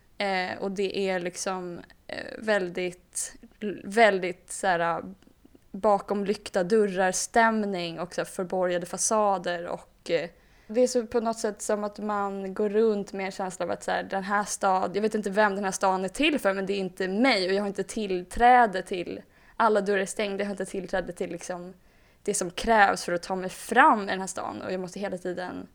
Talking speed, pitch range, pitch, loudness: 195 wpm, 185-215 Hz, 195 Hz, -27 LUFS